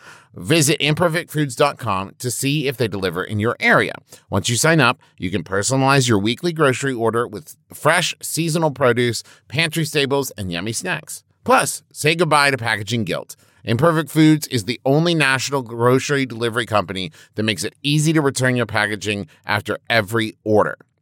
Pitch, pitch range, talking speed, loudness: 125 Hz, 110-150 Hz, 160 wpm, -19 LUFS